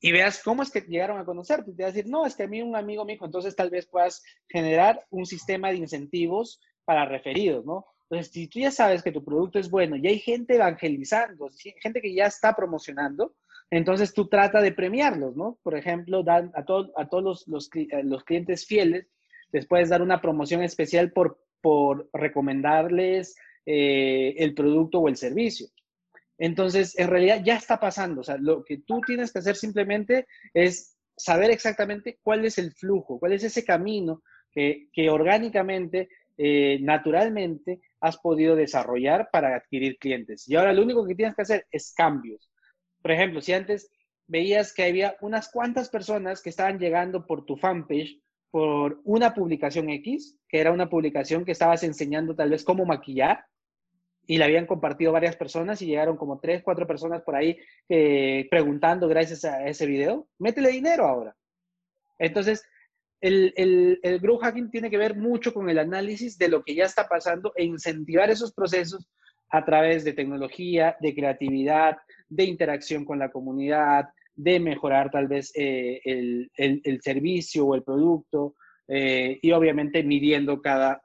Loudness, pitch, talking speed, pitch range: -25 LUFS, 175 Hz, 175 wpm, 150-200 Hz